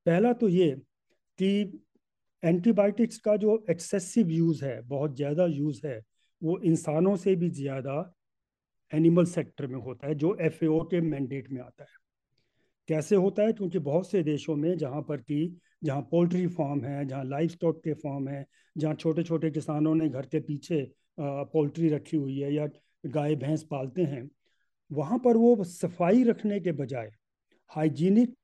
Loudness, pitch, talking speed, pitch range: -28 LUFS, 160 Hz, 165 wpm, 145-180 Hz